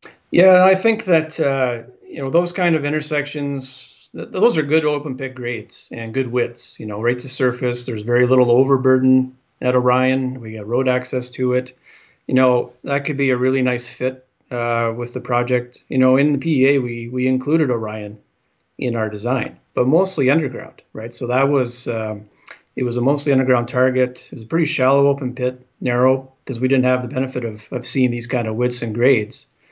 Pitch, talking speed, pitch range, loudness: 130 Hz, 200 wpm, 120-135 Hz, -19 LUFS